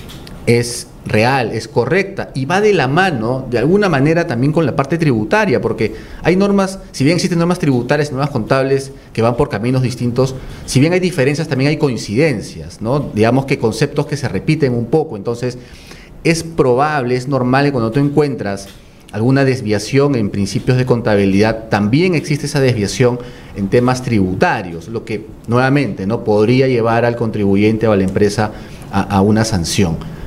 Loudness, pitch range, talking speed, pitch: -15 LUFS, 110-145 Hz, 170 wpm, 125 Hz